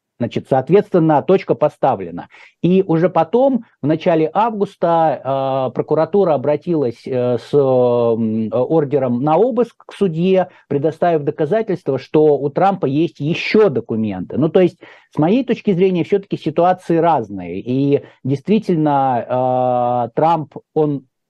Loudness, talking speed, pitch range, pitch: -16 LUFS, 115 wpm, 135-180 Hz, 155 Hz